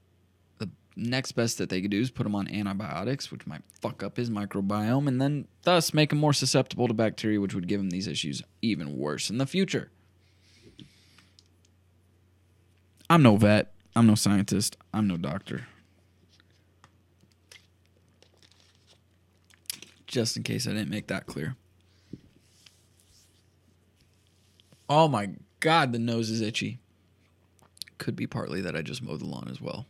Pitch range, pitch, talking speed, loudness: 90-115 Hz, 100 Hz, 145 wpm, -27 LUFS